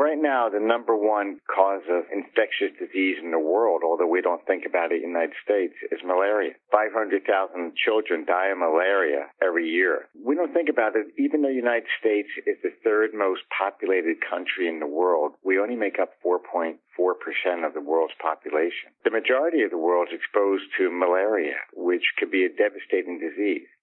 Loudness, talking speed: -24 LUFS, 185 wpm